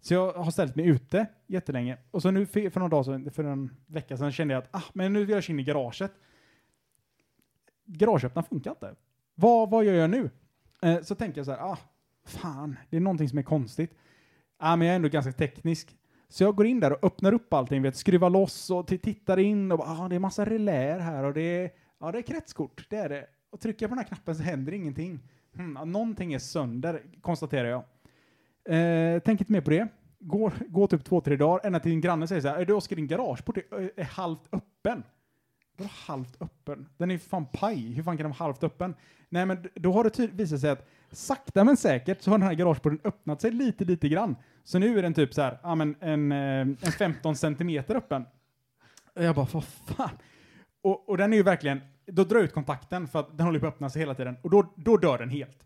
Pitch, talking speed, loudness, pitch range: 170 Hz, 235 wpm, -28 LUFS, 145-195 Hz